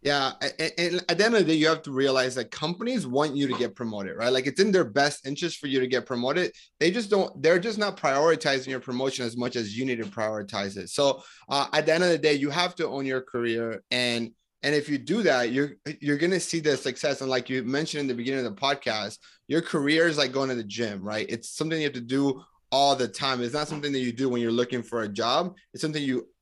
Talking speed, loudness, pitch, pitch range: 270 wpm, -26 LUFS, 140 Hz, 125-155 Hz